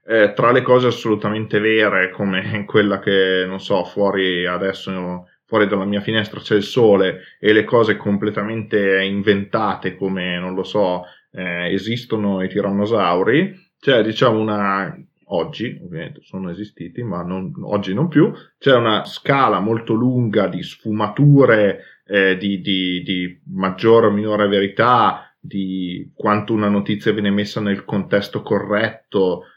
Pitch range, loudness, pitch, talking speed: 95-110 Hz, -18 LUFS, 100 Hz, 145 wpm